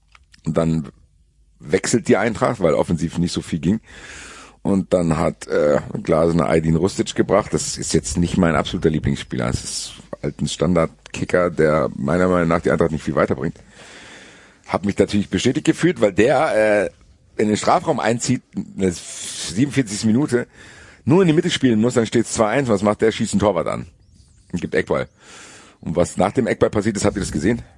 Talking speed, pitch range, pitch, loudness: 185 wpm, 85-115 Hz, 100 Hz, -19 LUFS